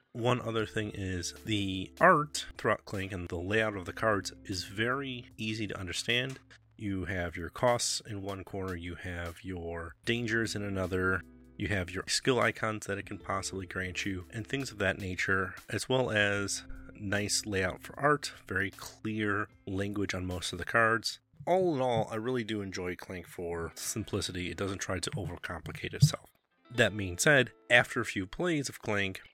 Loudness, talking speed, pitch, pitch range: -32 LUFS, 180 wpm, 100 Hz, 95-115 Hz